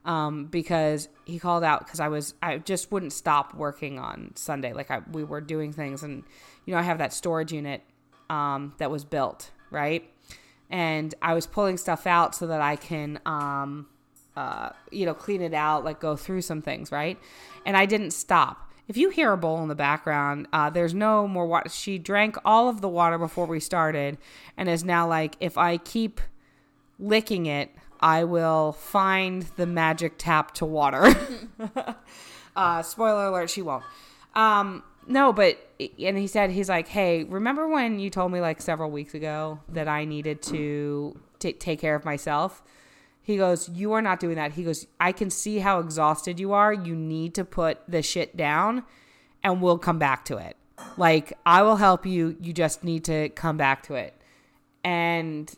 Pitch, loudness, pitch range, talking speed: 165 Hz, -25 LUFS, 155-190 Hz, 190 wpm